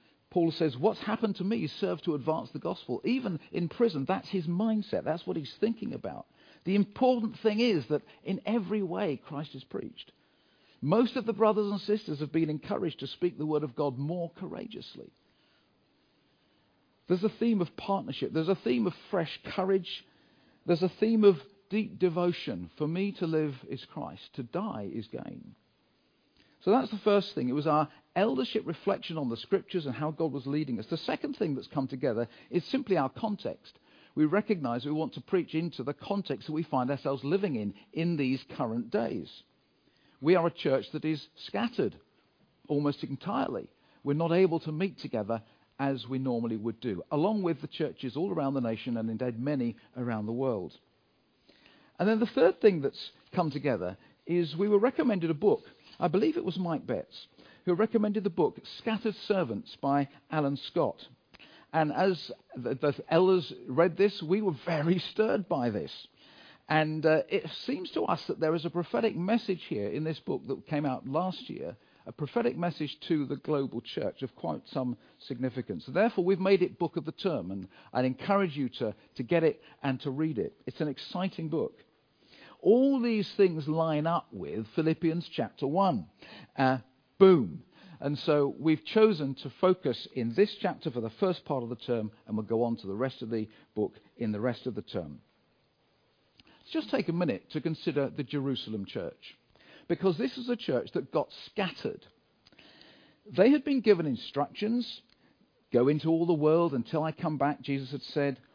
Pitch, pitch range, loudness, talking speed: 160 Hz, 135-195 Hz, -31 LUFS, 185 wpm